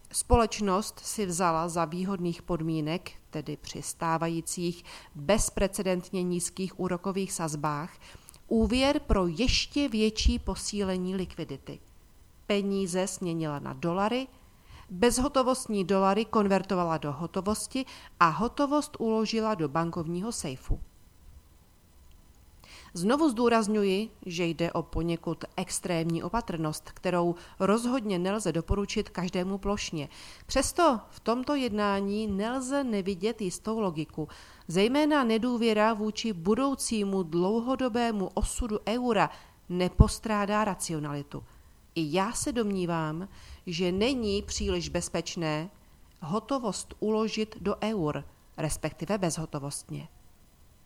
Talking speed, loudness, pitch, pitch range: 95 wpm, -29 LUFS, 190 Hz, 165-220 Hz